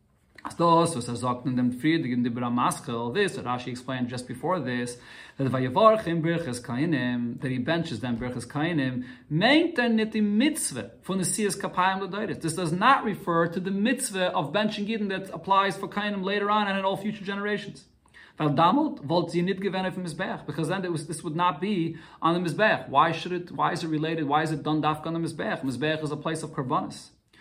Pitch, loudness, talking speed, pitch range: 170 Hz, -26 LUFS, 190 wpm, 145-195 Hz